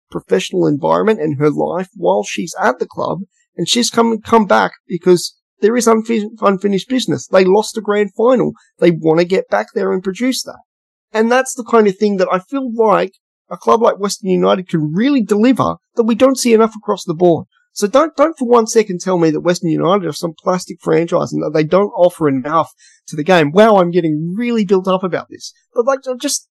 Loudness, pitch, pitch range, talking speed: -15 LUFS, 205 Hz, 175-230 Hz, 220 wpm